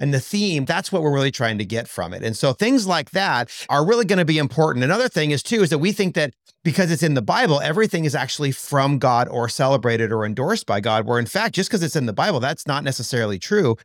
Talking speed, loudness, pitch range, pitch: 260 wpm, -20 LUFS, 125-180 Hz, 145 Hz